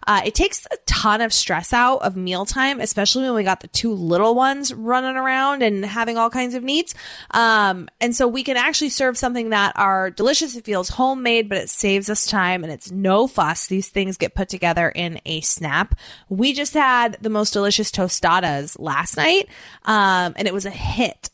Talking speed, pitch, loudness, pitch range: 205 wpm, 215 Hz, -19 LUFS, 190-255 Hz